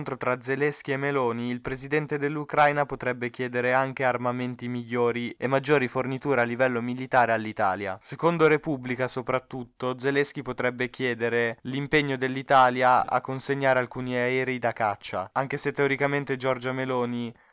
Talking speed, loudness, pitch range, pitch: 130 wpm, -26 LUFS, 125-140 Hz, 130 Hz